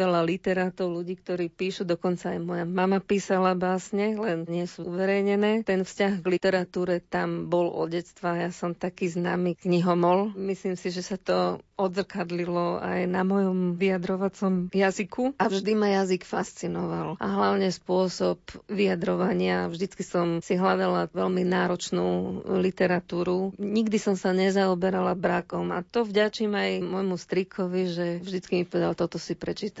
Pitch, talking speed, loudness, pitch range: 185 Hz, 145 wpm, -27 LUFS, 175-195 Hz